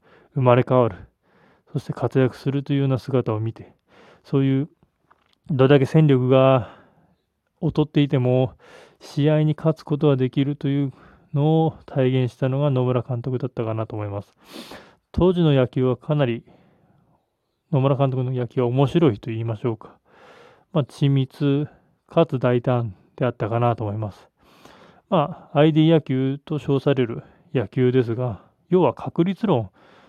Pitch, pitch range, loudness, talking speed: 135 Hz, 125-150 Hz, -21 LUFS, 285 characters per minute